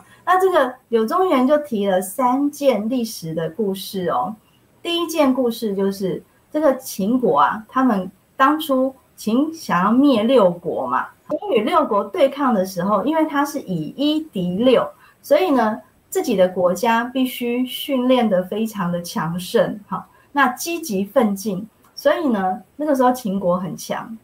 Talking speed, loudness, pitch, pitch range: 230 characters per minute, -19 LUFS, 245 Hz, 195-275 Hz